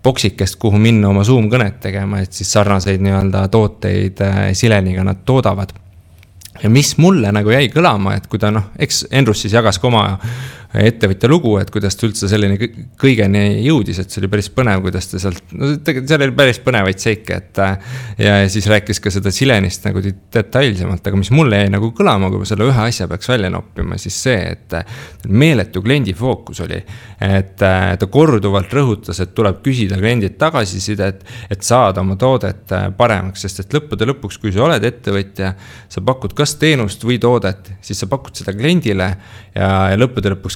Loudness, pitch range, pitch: -15 LUFS, 95-120 Hz, 105 Hz